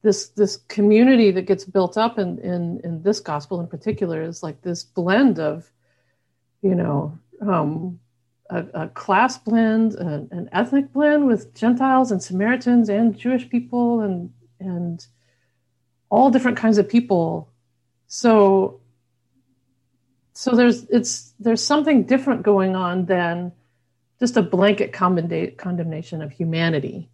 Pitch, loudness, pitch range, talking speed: 185 Hz, -20 LUFS, 150-225 Hz, 135 wpm